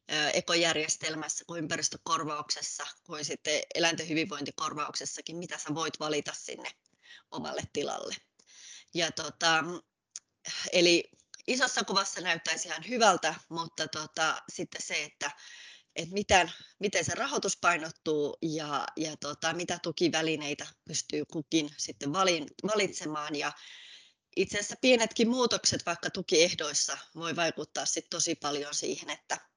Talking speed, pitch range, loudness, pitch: 115 wpm, 150-175 Hz, -30 LUFS, 160 Hz